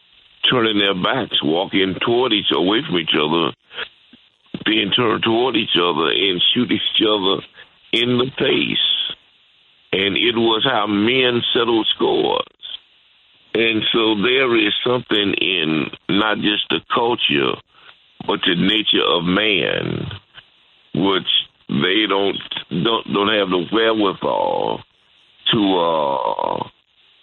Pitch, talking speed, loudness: 115 Hz, 120 wpm, -17 LUFS